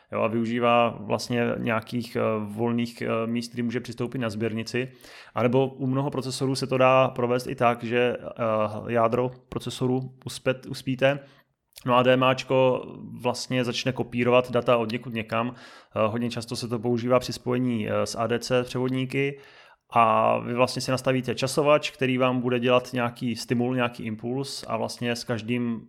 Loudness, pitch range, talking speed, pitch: -25 LUFS, 120-130 Hz, 150 wpm, 125 Hz